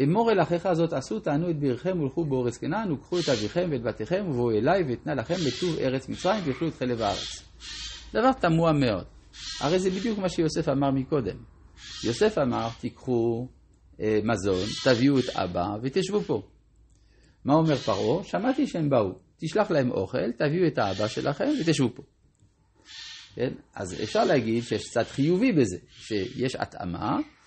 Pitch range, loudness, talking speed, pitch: 120-175 Hz, -27 LUFS, 155 wpm, 140 Hz